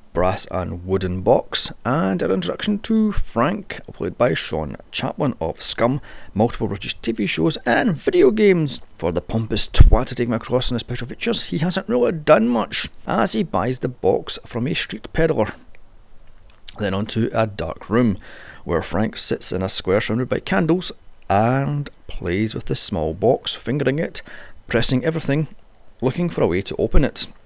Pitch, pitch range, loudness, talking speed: 120 Hz, 105-160 Hz, -20 LUFS, 175 wpm